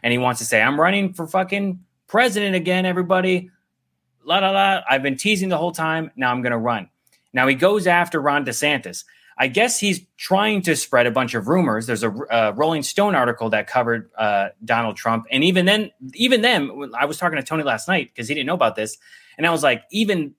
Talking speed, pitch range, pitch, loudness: 220 wpm, 120-185 Hz, 160 Hz, -19 LUFS